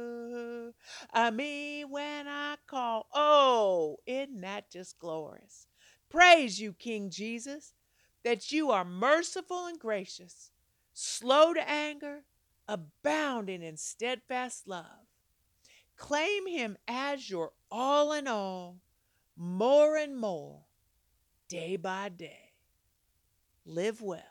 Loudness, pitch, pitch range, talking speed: -30 LUFS, 235 Hz, 180-290 Hz, 110 wpm